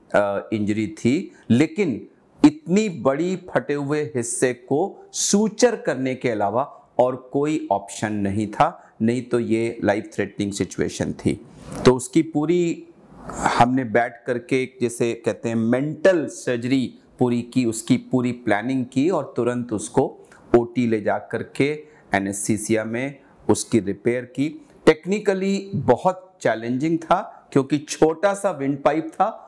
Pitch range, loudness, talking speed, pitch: 115-155 Hz, -22 LUFS, 130 wpm, 130 Hz